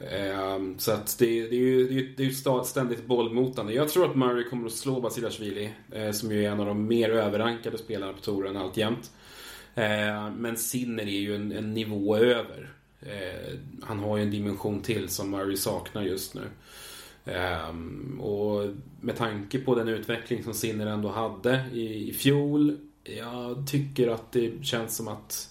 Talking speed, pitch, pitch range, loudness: 165 wpm, 115 Hz, 105-125 Hz, -29 LUFS